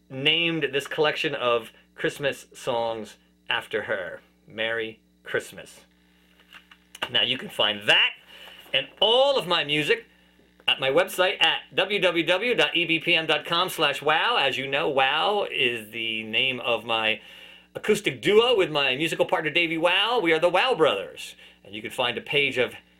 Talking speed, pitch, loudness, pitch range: 140 wpm, 150 Hz, -23 LUFS, 115-175 Hz